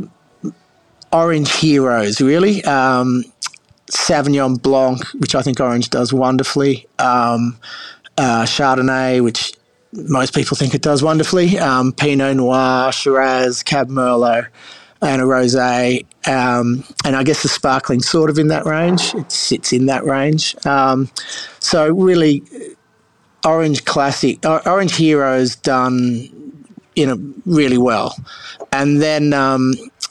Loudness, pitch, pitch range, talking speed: -15 LUFS, 135 Hz, 125-150 Hz, 120 wpm